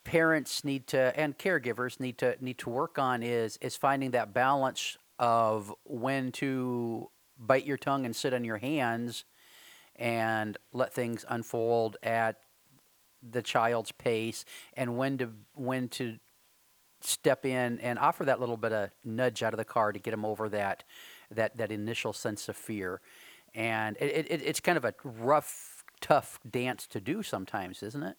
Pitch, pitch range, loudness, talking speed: 120 Hz, 115-130 Hz, -32 LUFS, 170 wpm